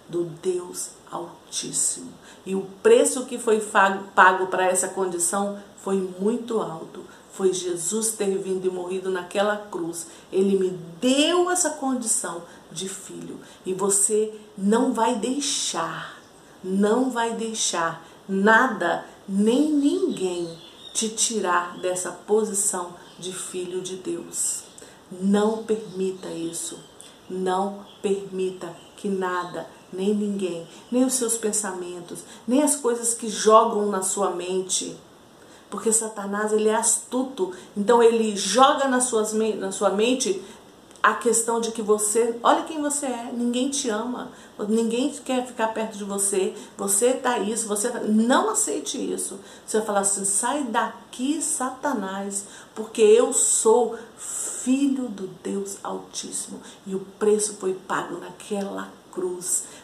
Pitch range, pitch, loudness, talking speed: 190-235 Hz, 210 Hz, -23 LUFS, 130 wpm